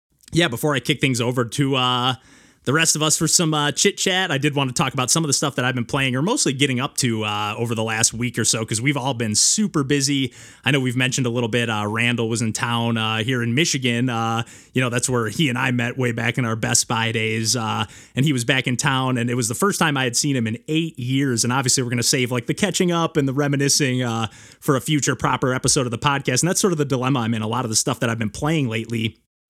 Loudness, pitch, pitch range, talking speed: -20 LUFS, 130 Hz, 120-145 Hz, 285 wpm